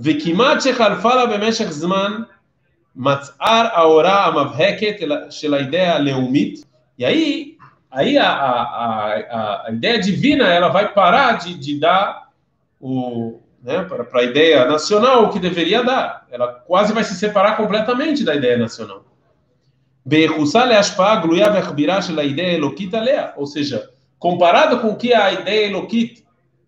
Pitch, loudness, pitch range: 190 Hz, -16 LUFS, 145-225 Hz